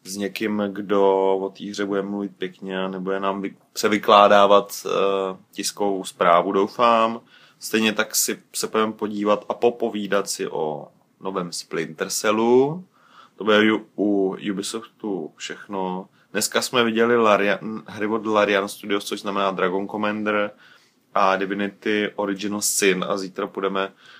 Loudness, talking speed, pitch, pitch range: -22 LUFS, 135 wpm, 100 Hz, 95-105 Hz